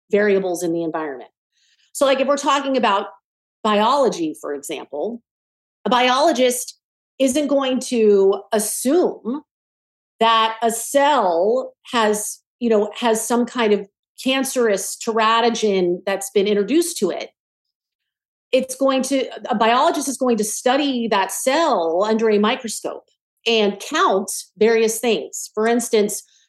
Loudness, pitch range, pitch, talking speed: -19 LUFS, 210-260 Hz, 230 Hz, 125 wpm